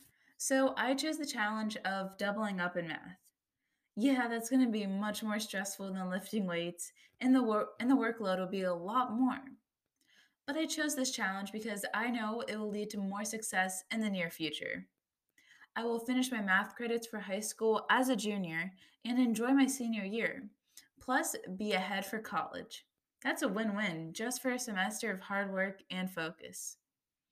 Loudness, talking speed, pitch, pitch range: -35 LUFS, 185 wpm, 215 Hz, 190-245 Hz